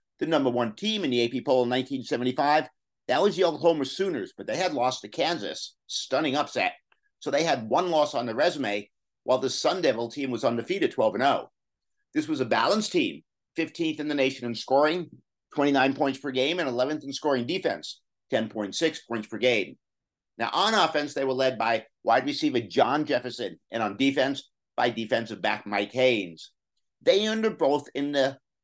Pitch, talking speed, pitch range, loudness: 135 Hz, 185 wpm, 120-160 Hz, -26 LUFS